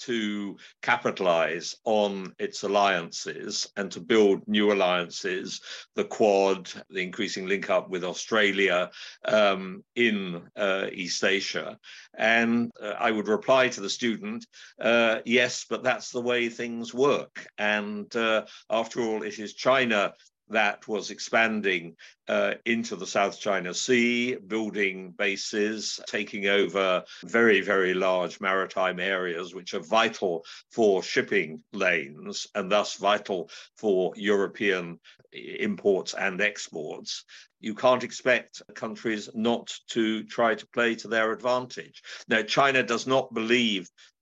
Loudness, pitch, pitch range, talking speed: -26 LUFS, 110 Hz, 100-120 Hz, 130 wpm